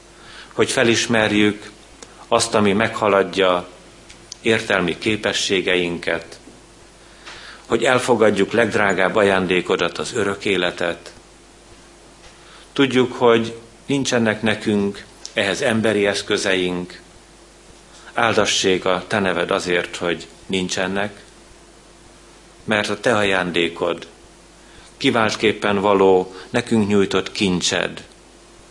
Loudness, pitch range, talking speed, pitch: -19 LUFS, 95-115 Hz, 75 wpm, 100 Hz